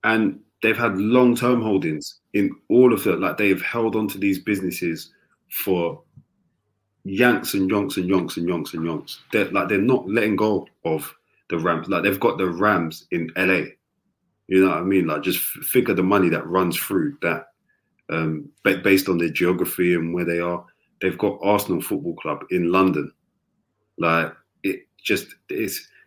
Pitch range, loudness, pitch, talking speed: 85-100 Hz, -22 LUFS, 95 Hz, 175 wpm